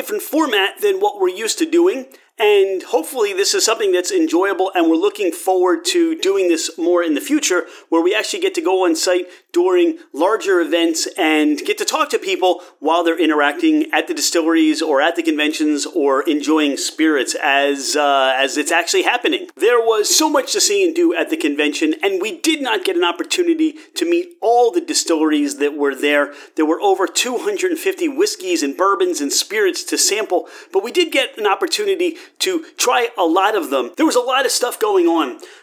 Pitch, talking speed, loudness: 335 Hz, 205 wpm, -17 LUFS